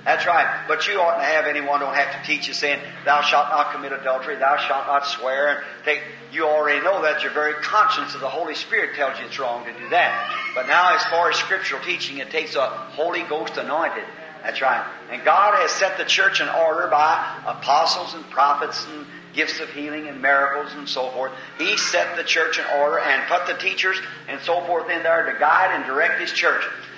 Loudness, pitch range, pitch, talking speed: -20 LUFS, 140-165 Hz, 150 Hz, 225 wpm